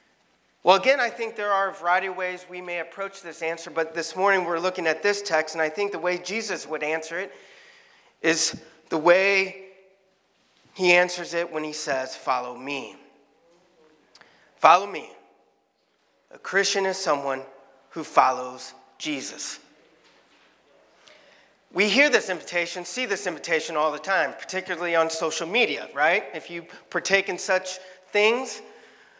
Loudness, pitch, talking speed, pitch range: -24 LUFS, 180 Hz, 150 wpm, 160-195 Hz